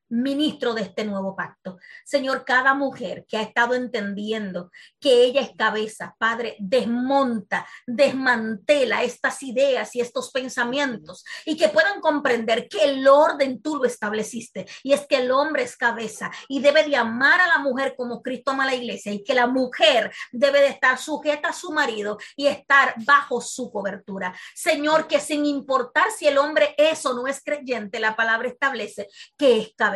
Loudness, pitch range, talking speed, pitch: -21 LUFS, 225-285 Hz, 175 wpm, 255 Hz